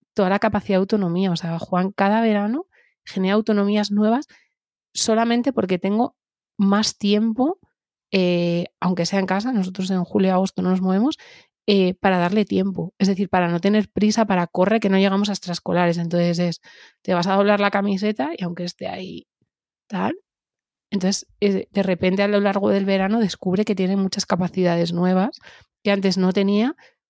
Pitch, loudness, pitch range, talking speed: 195 Hz, -21 LUFS, 185-210 Hz, 170 wpm